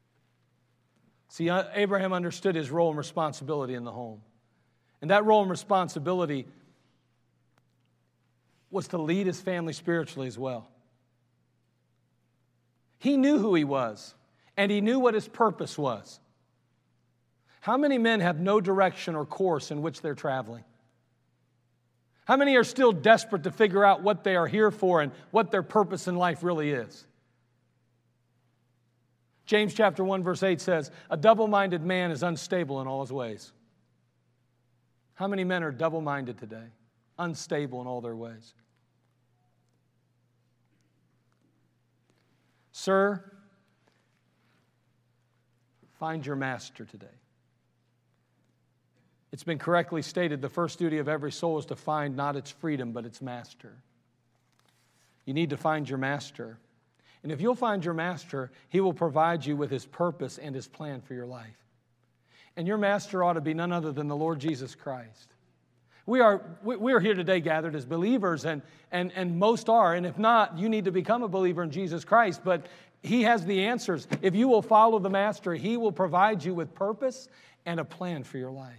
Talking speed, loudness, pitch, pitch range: 155 wpm, -27 LUFS, 155 Hz, 125-190 Hz